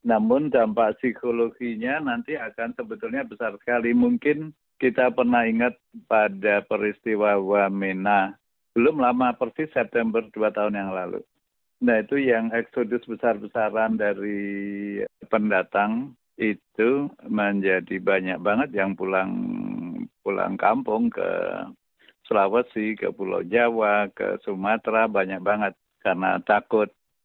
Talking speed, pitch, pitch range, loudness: 110 wpm, 115 Hz, 100-125 Hz, -24 LUFS